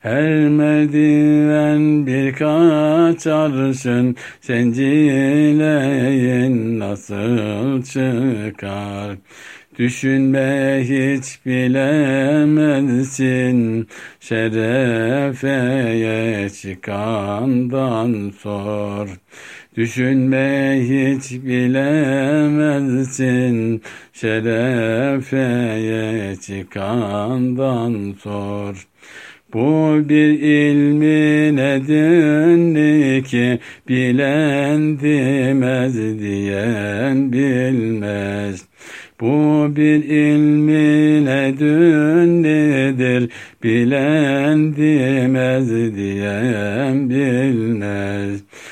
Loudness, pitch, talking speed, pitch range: -16 LUFS, 130 Hz, 45 wpm, 115-150 Hz